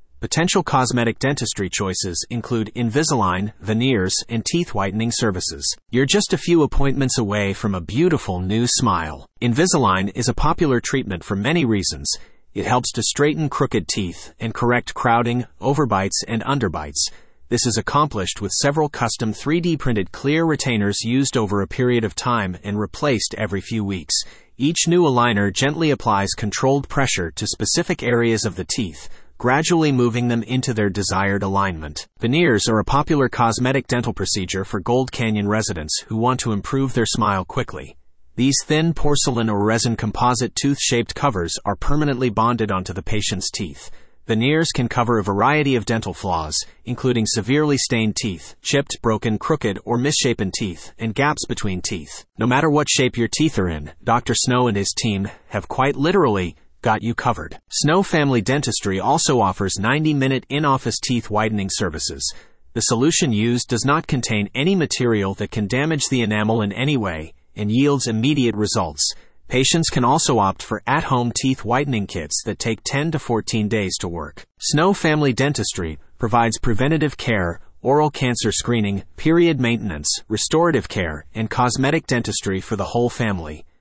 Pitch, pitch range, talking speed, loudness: 115 Hz, 100-135 Hz, 165 wpm, -20 LUFS